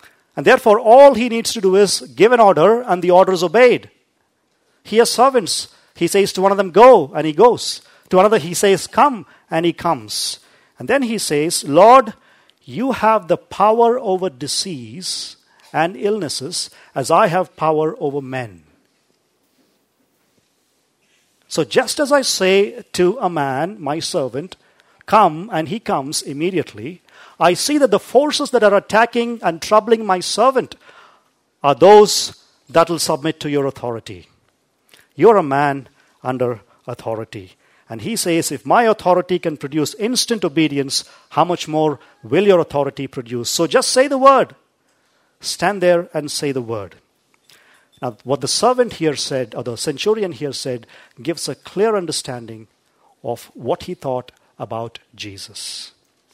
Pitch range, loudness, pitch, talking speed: 140-210 Hz, -16 LUFS, 170 Hz, 155 wpm